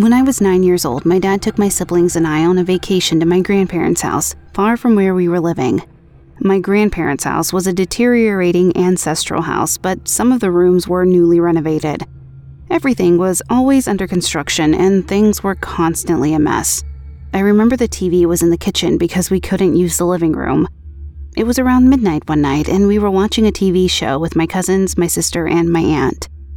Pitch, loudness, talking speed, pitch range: 180 Hz, -14 LUFS, 200 wpm, 165-195 Hz